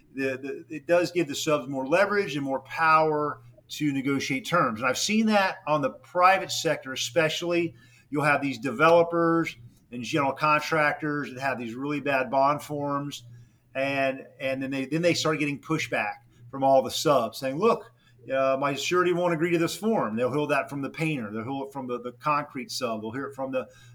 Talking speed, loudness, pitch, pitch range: 200 wpm, -26 LUFS, 140 Hz, 130-160 Hz